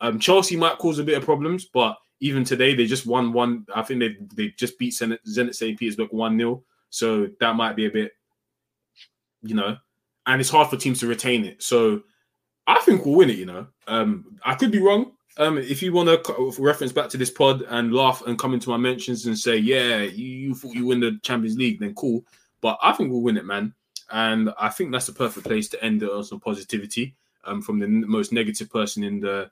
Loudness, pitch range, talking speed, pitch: -22 LUFS, 115-155 Hz, 235 wpm, 125 Hz